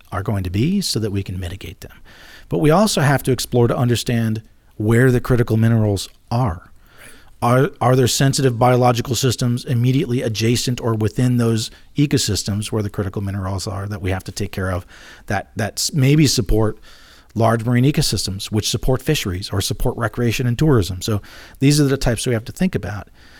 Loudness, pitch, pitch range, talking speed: -19 LUFS, 115 Hz, 105-130 Hz, 185 wpm